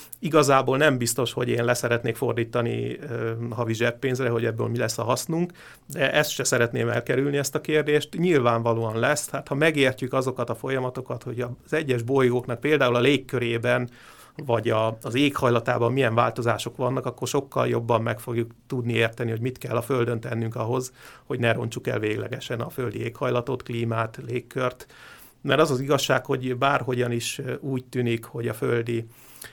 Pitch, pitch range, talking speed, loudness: 125 Hz, 120-135 Hz, 165 wpm, -25 LUFS